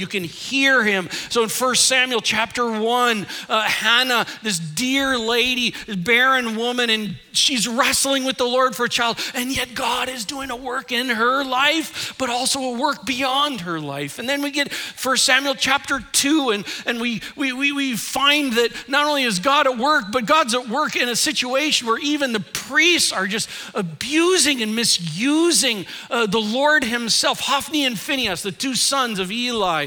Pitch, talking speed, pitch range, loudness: 250 Hz, 190 wpm, 225-275 Hz, -19 LUFS